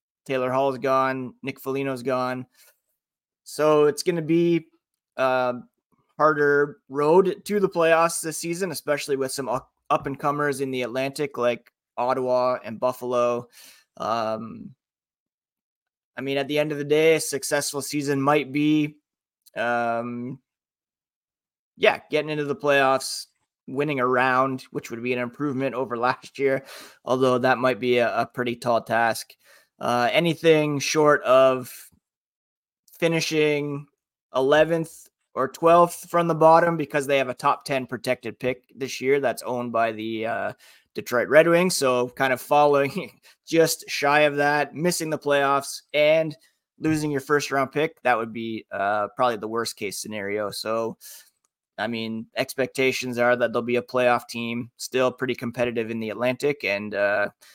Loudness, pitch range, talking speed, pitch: -23 LUFS, 125-150 Hz, 155 wpm, 135 Hz